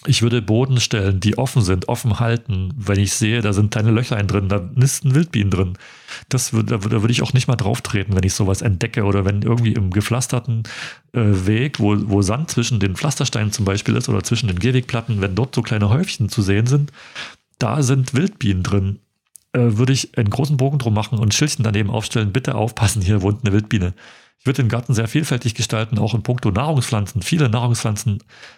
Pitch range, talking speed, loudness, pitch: 105-125 Hz, 205 wpm, -19 LUFS, 115 Hz